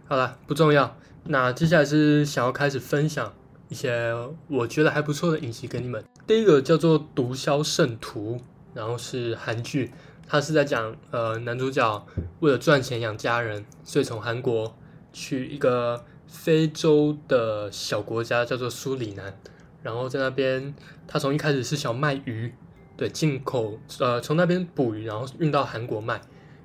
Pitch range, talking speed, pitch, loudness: 120-150 Hz, 245 characters per minute, 135 Hz, -25 LUFS